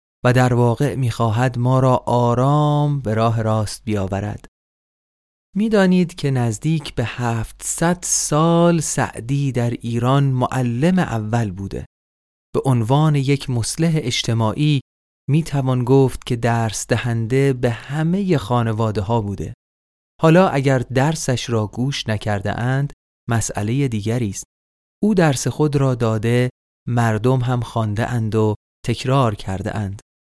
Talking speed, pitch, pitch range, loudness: 120 wpm, 120 Hz, 110-140 Hz, -19 LUFS